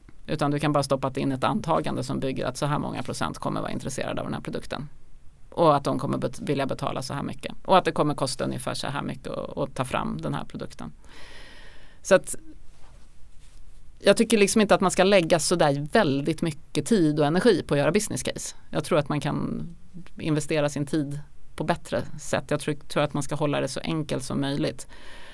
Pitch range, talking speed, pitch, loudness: 145-175 Hz, 215 wpm, 150 Hz, -25 LUFS